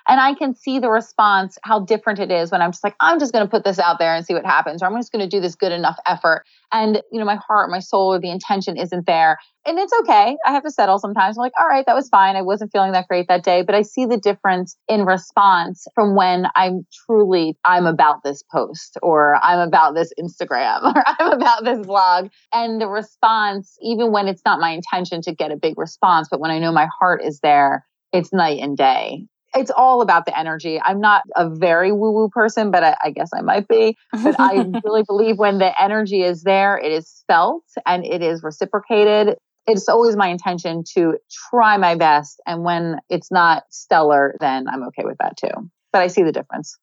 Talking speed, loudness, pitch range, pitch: 230 wpm, -17 LUFS, 175-220 Hz, 195 Hz